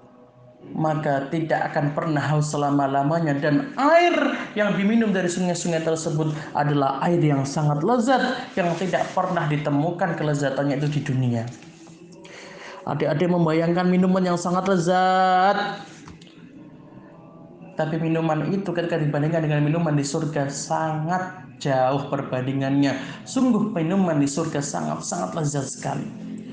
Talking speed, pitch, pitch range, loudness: 115 wpm, 160 Hz, 145-185 Hz, -22 LUFS